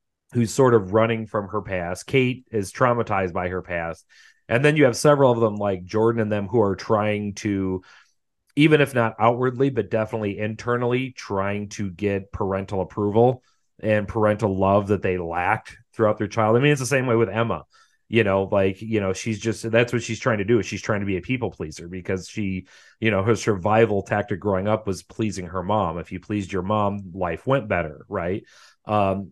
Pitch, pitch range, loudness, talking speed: 105 Hz, 95-115 Hz, -23 LUFS, 205 wpm